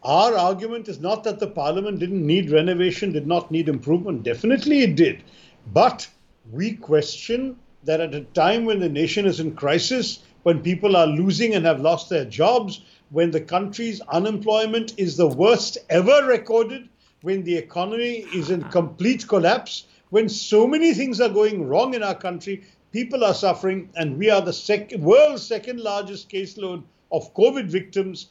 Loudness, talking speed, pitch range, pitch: -21 LUFS, 170 wpm, 170-225 Hz, 195 Hz